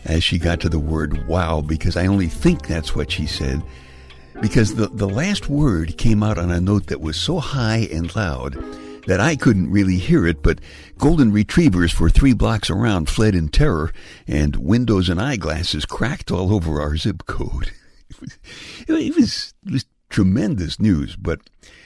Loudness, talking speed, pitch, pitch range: -19 LUFS, 175 wpm, 90 Hz, 80-110 Hz